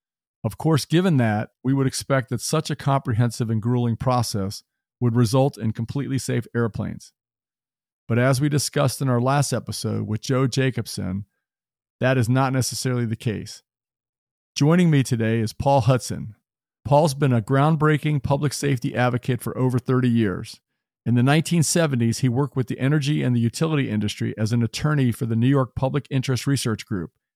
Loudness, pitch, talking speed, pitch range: -22 LUFS, 125 Hz, 170 wpm, 115-140 Hz